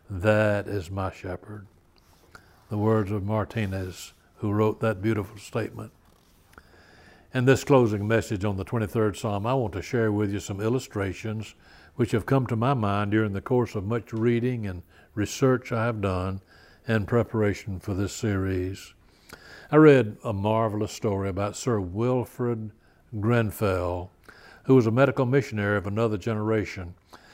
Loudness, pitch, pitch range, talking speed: -26 LUFS, 105 Hz, 95-115 Hz, 150 wpm